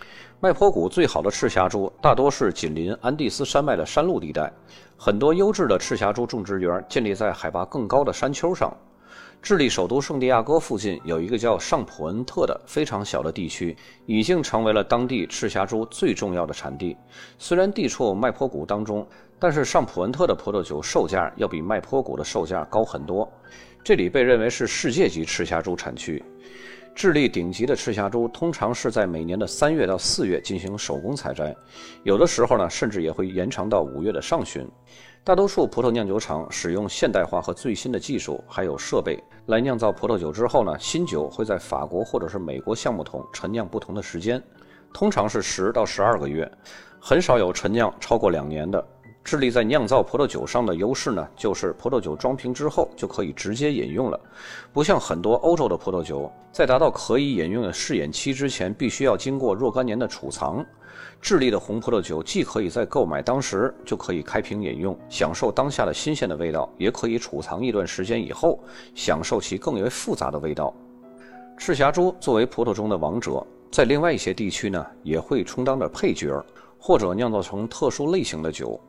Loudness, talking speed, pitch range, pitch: -24 LUFS, 305 characters per minute, 95-130 Hz, 115 Hz